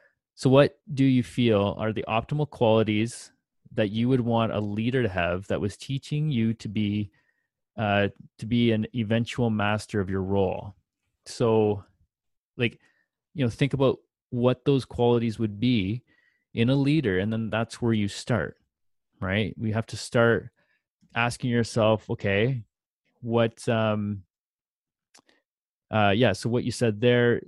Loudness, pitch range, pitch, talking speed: -26 LUFS, 105-120 Hz, 115 Hz, 150 wpm